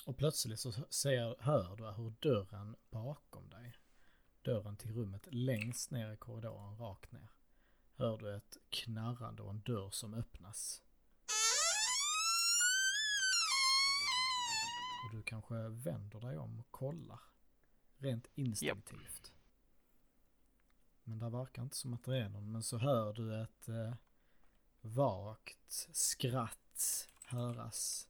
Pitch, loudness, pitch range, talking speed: 120 Hz, -38 LUFS, 110-140 Hz, 120 wpm